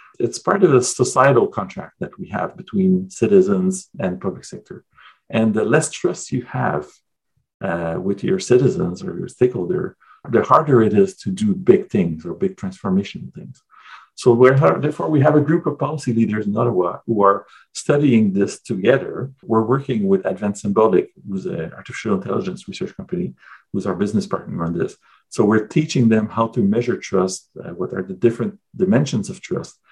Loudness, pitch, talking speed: -19 LUFS, 125 Hz, 180 wpm